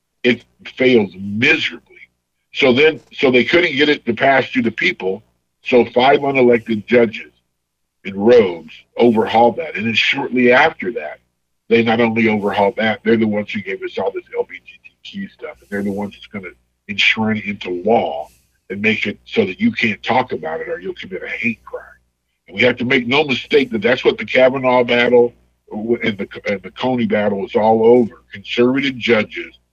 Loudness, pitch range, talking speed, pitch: -16 LUFS, 100-130 Hz, 190 wpm, 115 Hz